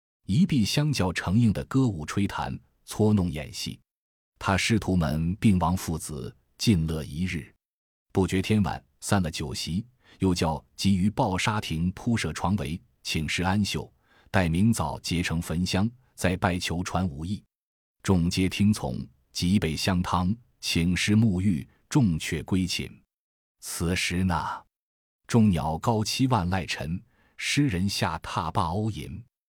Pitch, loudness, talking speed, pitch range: 95 Hz, -27 LUFS, 195 characters per minute, 85-105 Hz